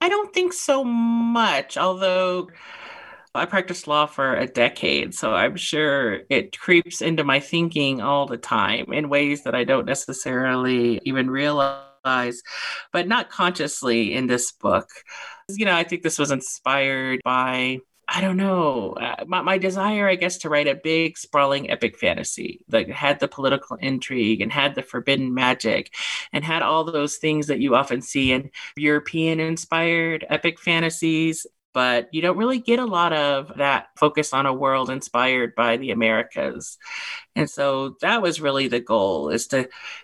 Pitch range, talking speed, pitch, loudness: 130-175 Hz, 165 wpm, 150 Hz, -22 LUFS